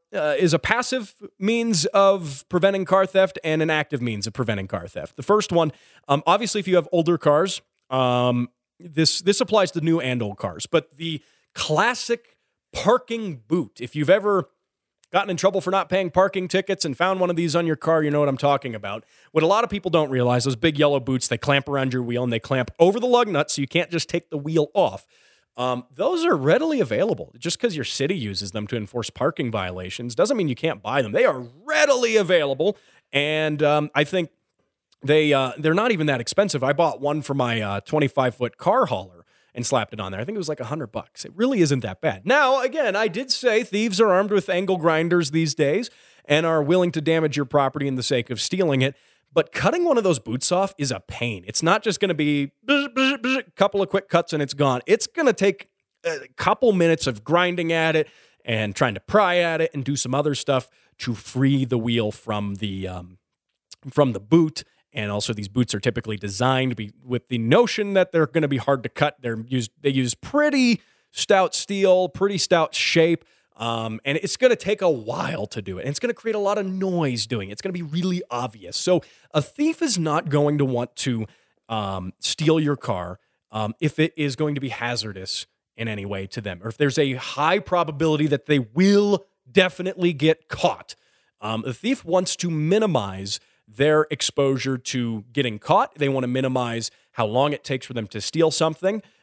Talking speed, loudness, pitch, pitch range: 215 wpm, -22 LUFS, 150 Hz, 125-185 Hz